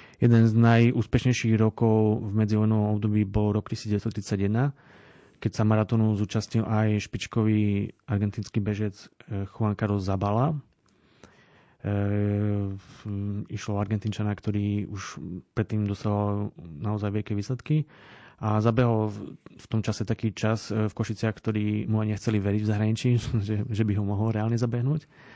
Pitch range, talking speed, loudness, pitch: 105-115 Hz, 130 wpm, -27 LUFS, 110 Hz